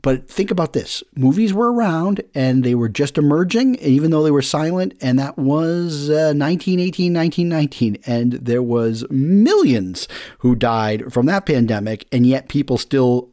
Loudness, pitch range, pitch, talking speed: -17 LUFS, 125-170 Hz, 140 Hz, 160 wpm